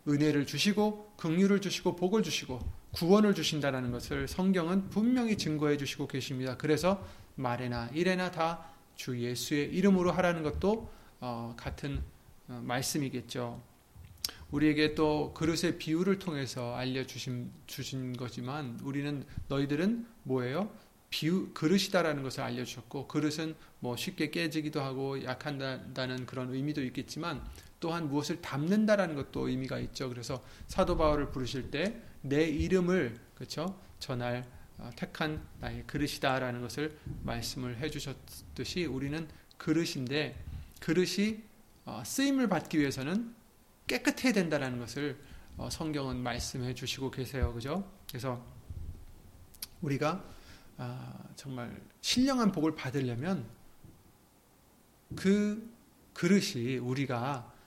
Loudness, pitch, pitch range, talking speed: -33 LUFS, 145 Hz, 125-175 Hz, 285 characters per minute